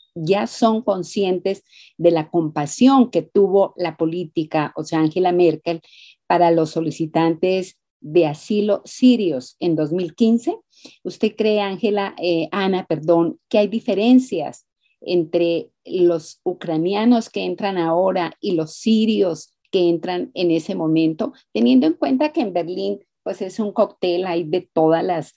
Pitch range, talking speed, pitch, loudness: 165-205 Hz, 140 wpm, 180 Hz, -19 LUFS